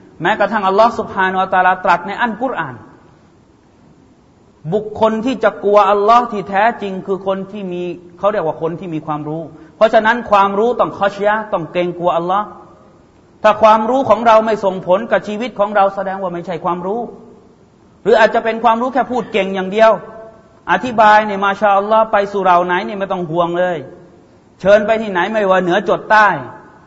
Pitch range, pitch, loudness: 185-220 Hz, 200 Hz, -14 LUFS